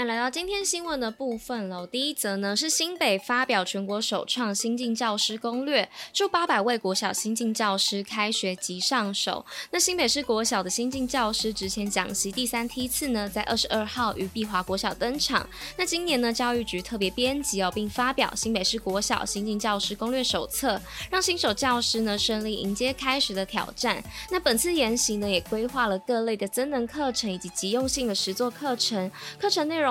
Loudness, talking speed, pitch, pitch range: -26 LUFS, 300 characters per minute, 230 Hz, 200-255 Hz